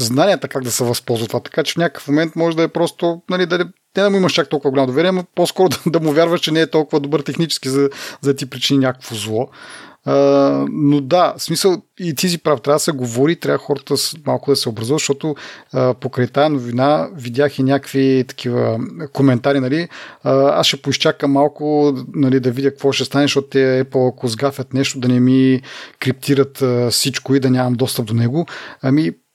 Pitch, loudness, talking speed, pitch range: 140 Hz, -17 LUFS, 205 wpm, 130-155 Hz